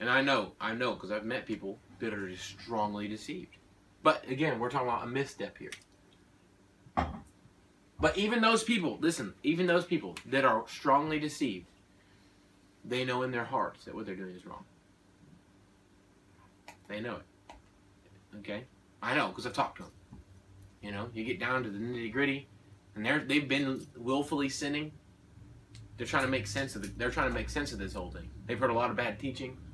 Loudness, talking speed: -33 LUFS, 190 wpm